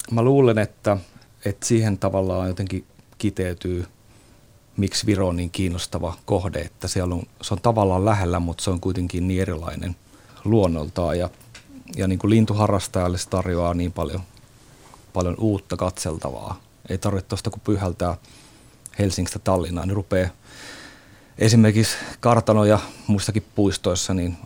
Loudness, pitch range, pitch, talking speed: -22 LUFS, 90-110 Hz, 100 Hz, 135 wpm